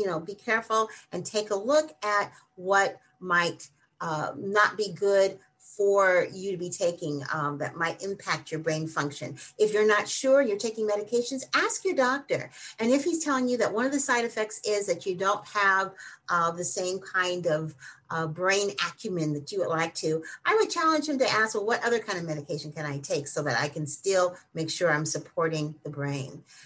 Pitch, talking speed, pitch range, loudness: 190 Hz, 205 wpm, 160-215 Hz, -27 LUFS